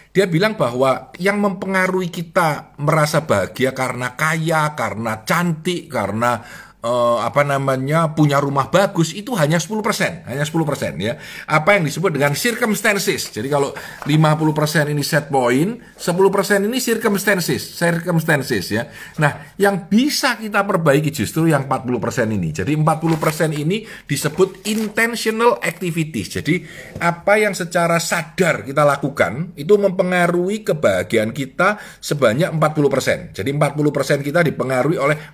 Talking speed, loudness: 125 wpm, -18 LUFS